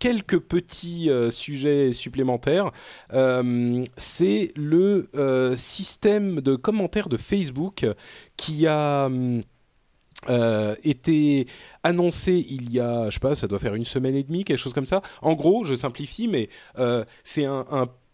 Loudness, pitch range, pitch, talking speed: -24 LUFS, 125-170 Hz, 140 Hz, 150 wpm